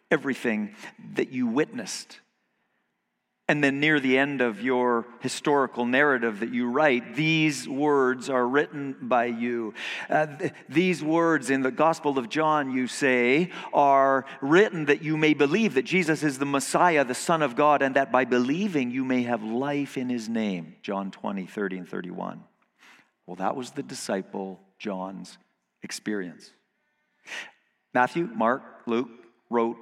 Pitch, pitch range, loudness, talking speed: 135 Hz, 120-155 Hz, -25 LUFS, 150 wpm